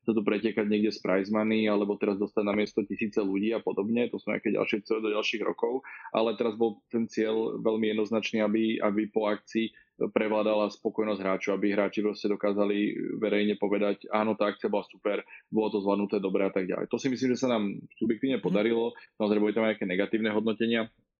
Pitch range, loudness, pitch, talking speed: 105-110 Hz, -29 LUFS, 105 Hz, 205 wpm